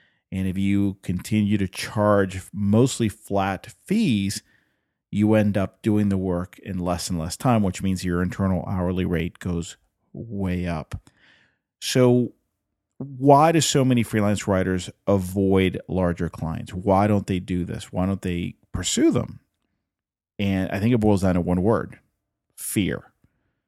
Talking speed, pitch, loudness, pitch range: 150 wpm, 100 Hz, -23 LUFS, 90-110 Hz